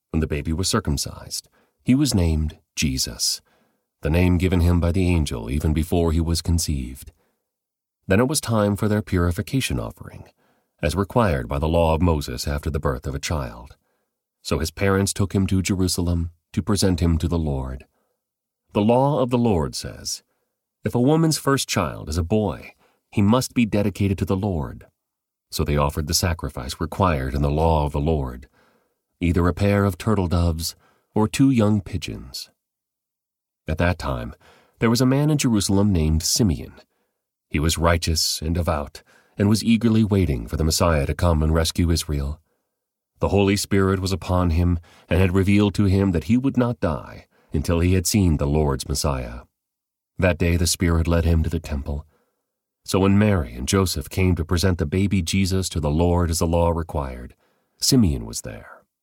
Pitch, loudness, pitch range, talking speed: 85 Hz, -22 LUFS, 80-100 Hz, 180 wpm